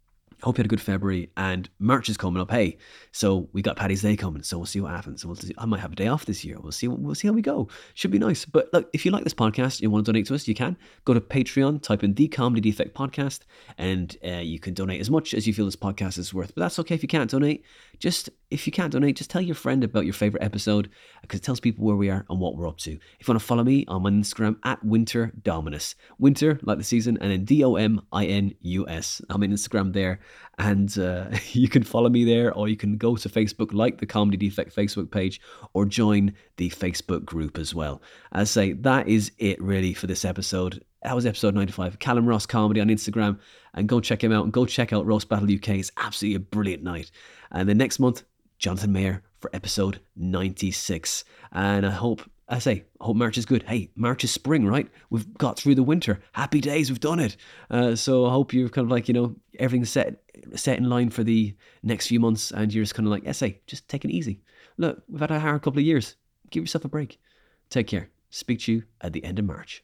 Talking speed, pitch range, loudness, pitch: 255 wpm, 95-120 Hz, -25 LUFS, 105 Hz